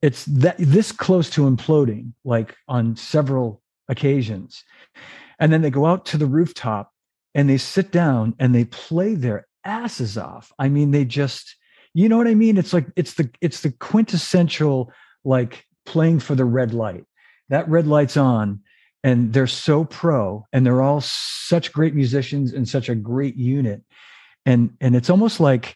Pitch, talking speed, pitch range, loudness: 140 Hz, 170 wpm, 125-165 Hz, -19 LUFS